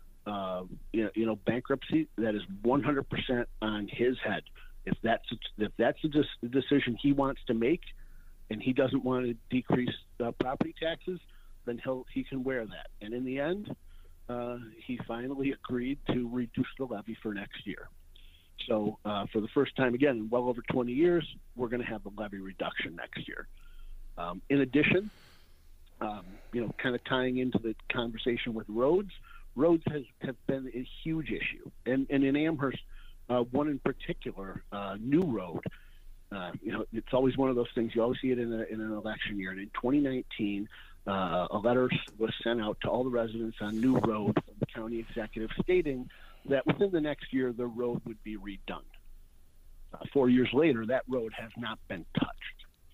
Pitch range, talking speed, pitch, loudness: 105-135 Hz, 190 wpm, 120 Hz, -32 LUFS